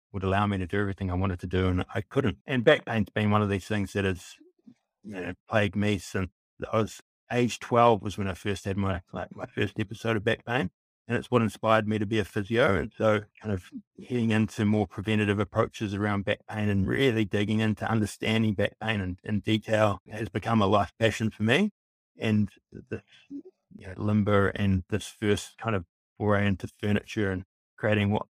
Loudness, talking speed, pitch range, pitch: -28 LUFS, 210 wpm, 100-110 Hz, 105 Hz